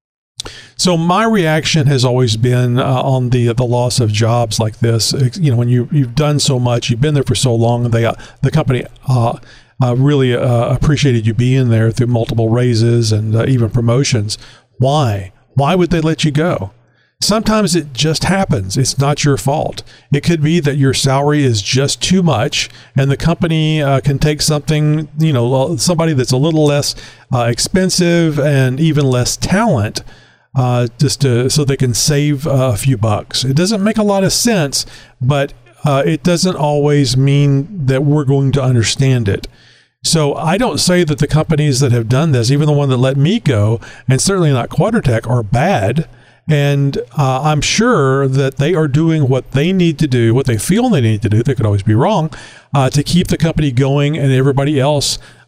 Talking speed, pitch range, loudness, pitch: 195 wpm, 120-150 Hz, -13 LUFS, 135 Hz